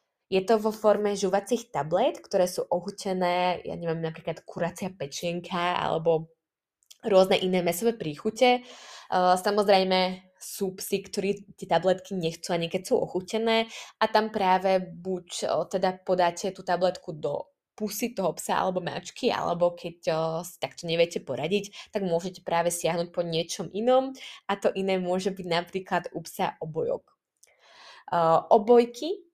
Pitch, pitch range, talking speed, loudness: 185 Hz, 175-205 Hz, 135 wpm, -27 LUFS